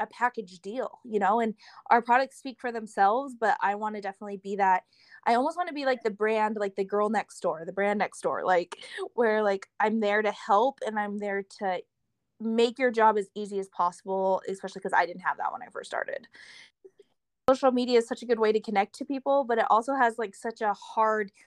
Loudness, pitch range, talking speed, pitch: -28 LUFS, 200-245 Hz, 230 wpm, 215 Hz